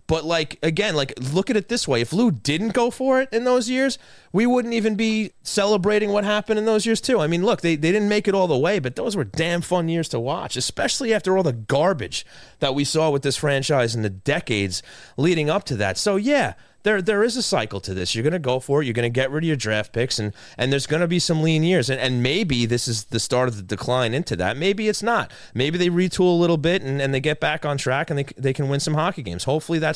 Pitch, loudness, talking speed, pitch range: 160 Hz, -21 LUFS, 275 wpm, 130-205 Hz